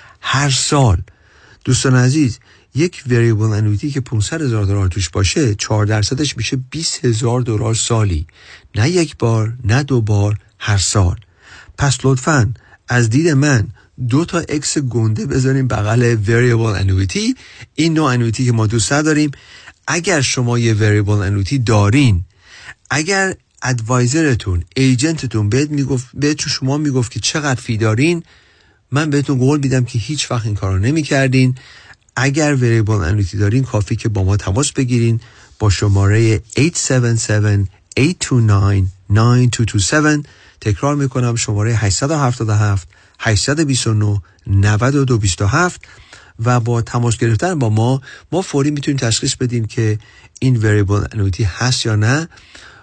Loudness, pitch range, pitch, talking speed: -16 LUFS, 105-135 Hz, 120 Hz, 130 wpm